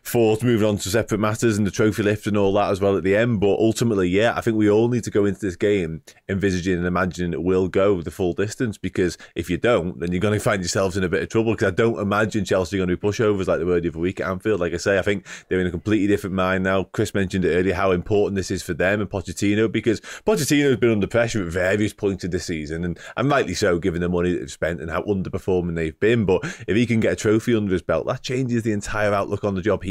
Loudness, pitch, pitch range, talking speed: -21 LUFS, 100 Hz, 95-110 Hz, 285 wpm